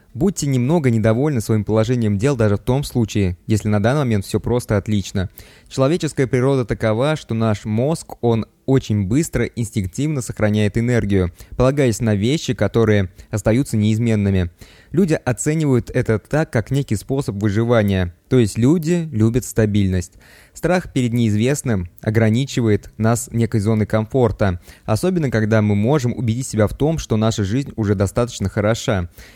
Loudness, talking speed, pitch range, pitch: -19 LUFS, 145 wpm, 105-130 Hz, 115 Hz